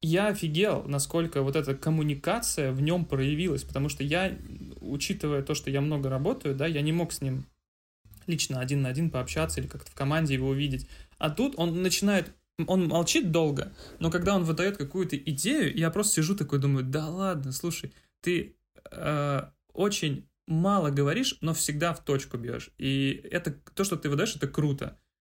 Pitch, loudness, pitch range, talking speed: 155 Hz, -29 LUFS, 140-175 Hz, 175 wpm